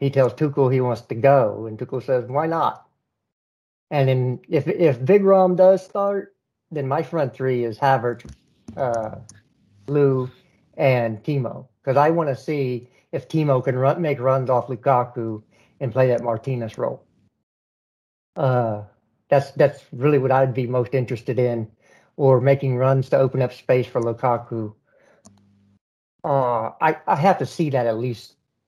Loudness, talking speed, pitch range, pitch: -21 LUFS, 160 wpm, 115-140 Hz, 130 Hz